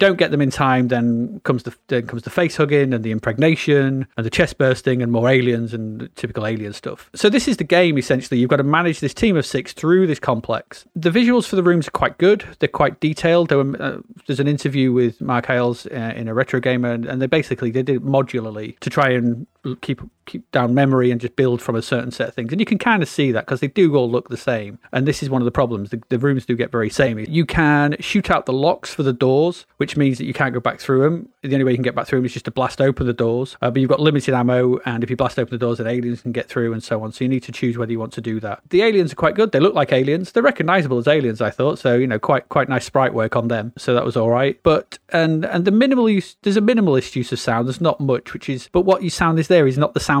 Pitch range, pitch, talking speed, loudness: 120-155 Hz, 130 Hz, 290 wpm, -18 LUFS